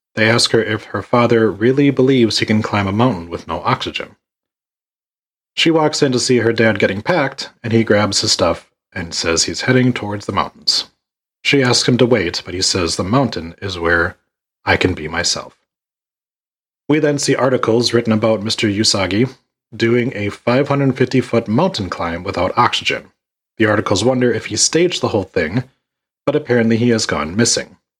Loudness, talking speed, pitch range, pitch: -16 LUFS, 180 wpm, 105-125 Hz, 115 Hz